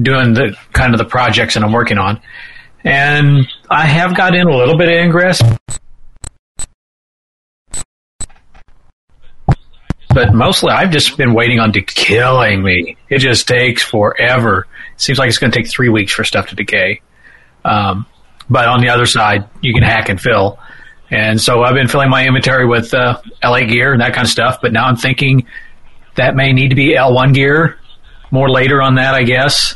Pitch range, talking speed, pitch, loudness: 115-135 Hz, 185 wpm, 125 Hz, -11 LUFS